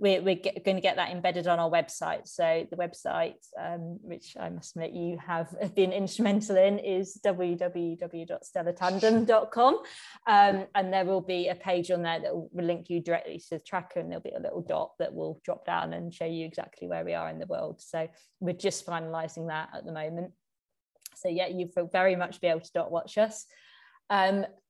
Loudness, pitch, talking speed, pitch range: -30 LUFS, 180 Hz, 200 wpm, 170-195 Hz